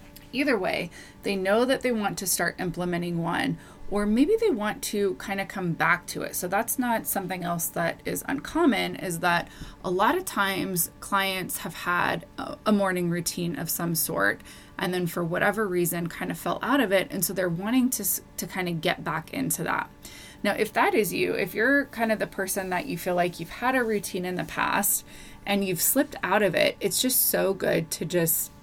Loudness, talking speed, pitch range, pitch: -26 LUFS, 215 wpm, 175-220 Hz, 195 Hz